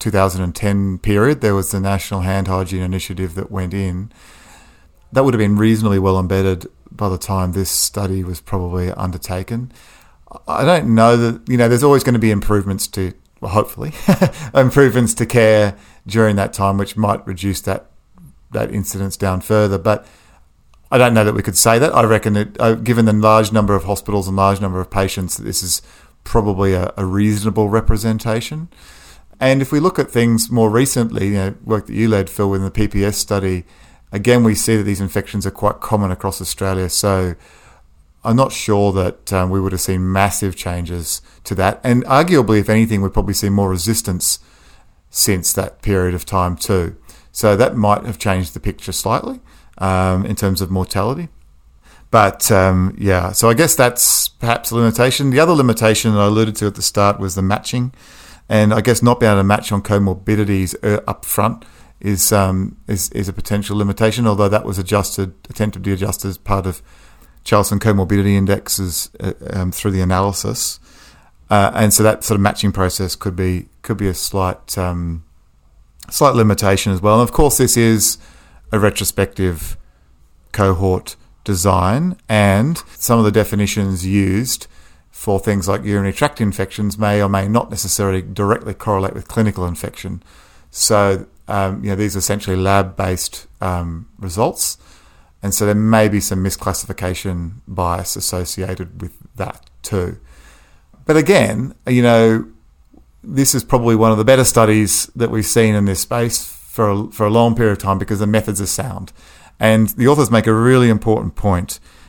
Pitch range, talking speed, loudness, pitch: 95-110 Hz, 175 wpm, -16 LUFS, 100 Hz